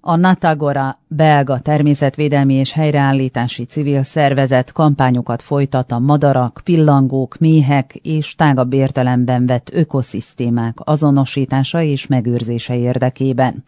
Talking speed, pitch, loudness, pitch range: 100 wpm, 135 Hz, -15 LUFS, 125-150 Hz